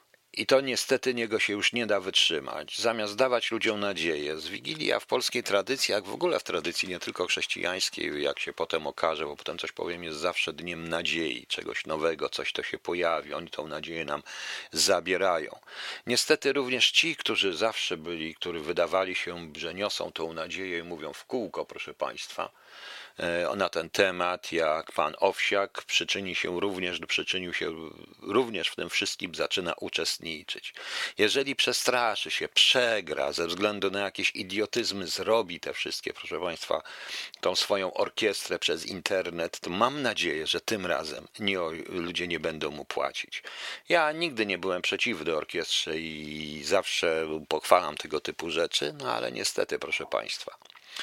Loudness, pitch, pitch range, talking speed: -28 LUFS, 95 Hz, 85-115 Hz, 155 wpm